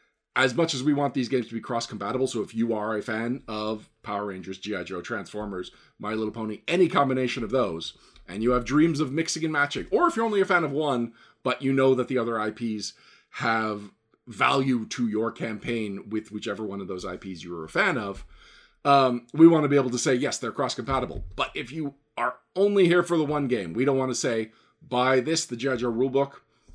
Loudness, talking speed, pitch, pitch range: -26 LUFS, 225 wpm, 125 Hz, 110-145 Hz